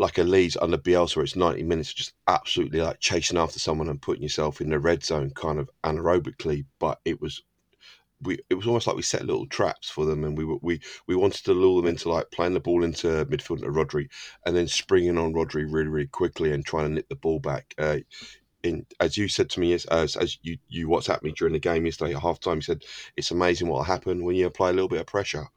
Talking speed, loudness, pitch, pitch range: 245 wpm, -26 LUFS, 85 Hz, 75-90 Hz